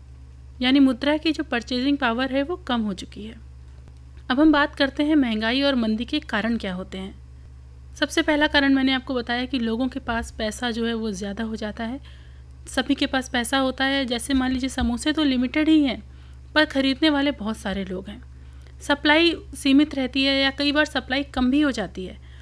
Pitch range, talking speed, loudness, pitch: 205-280 Hz, 205 wpm, -22 LUFS, 255 Hz